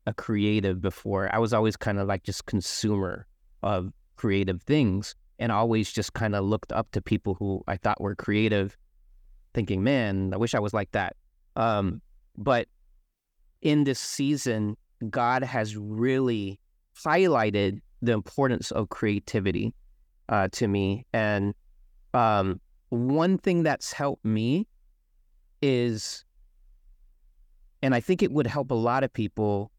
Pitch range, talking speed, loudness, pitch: 95-120 Hz, 140 wpm, -27 LUFS, 105 Hz